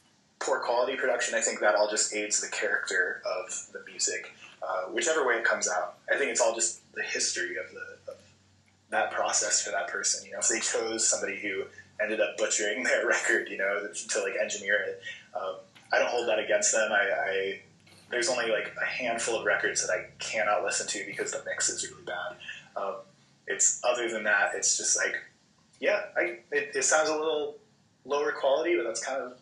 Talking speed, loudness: 205 wpm, -28 LUFS